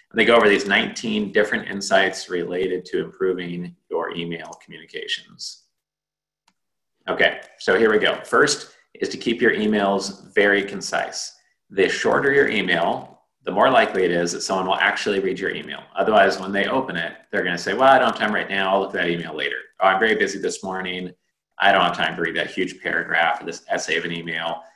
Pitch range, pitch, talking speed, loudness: 85-105 Hz, 95 Hz, 205 wpm, -21 LUFS